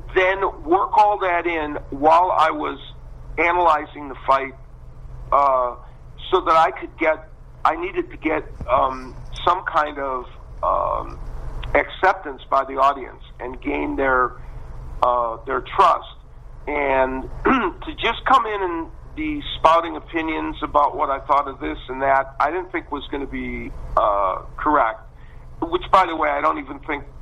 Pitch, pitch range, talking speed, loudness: 135 Hz, 120-165 Hz, 155 wpm, -20 LUFS